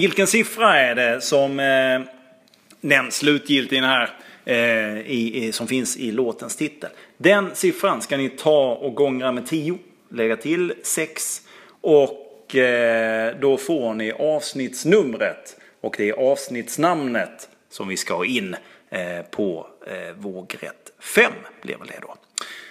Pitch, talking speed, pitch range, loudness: 130 Hz, 140 wpm, 115-150 Hz, -20 LUFS